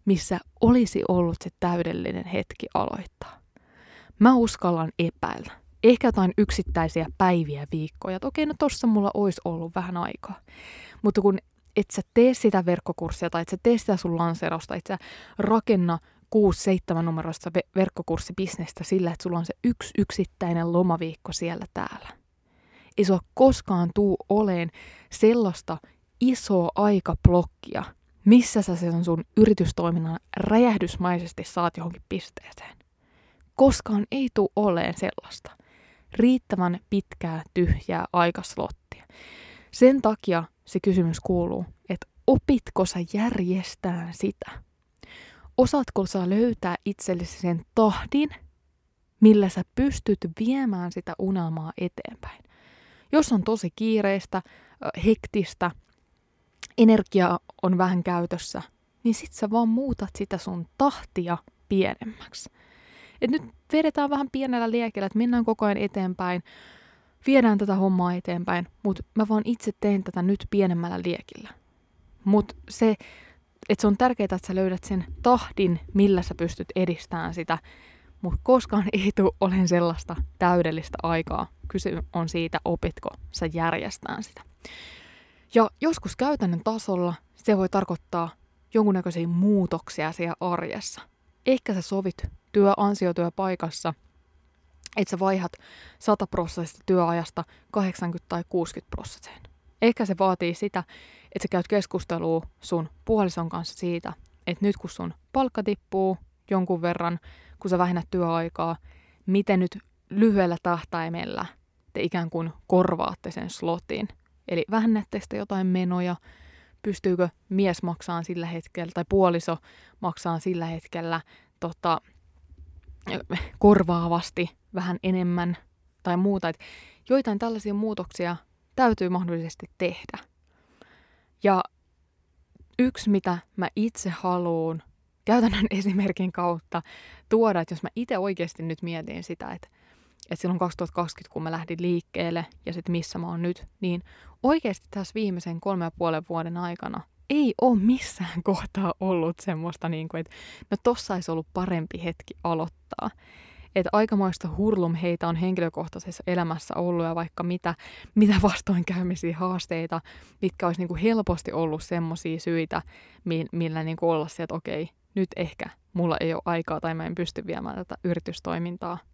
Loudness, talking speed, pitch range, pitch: -26 LUFS, 130 wpm, 170-205 Hz, 180 Hz